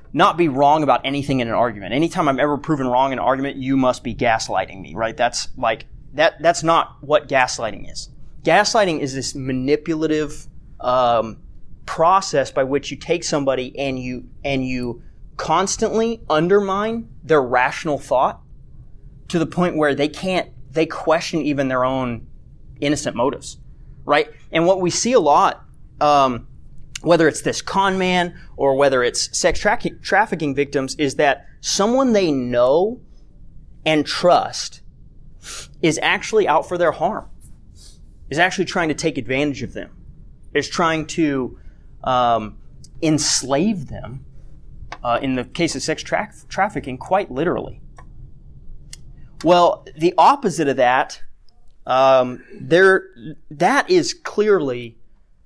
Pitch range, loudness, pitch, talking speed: 130-170 Hz, -19 LUFS, 145 Hz, 140 wpm